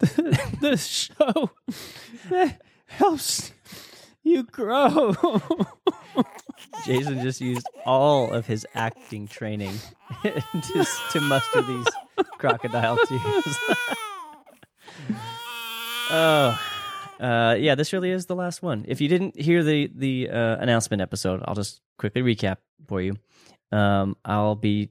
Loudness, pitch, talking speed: -24 LUFS, 145 Hz, 115 wpm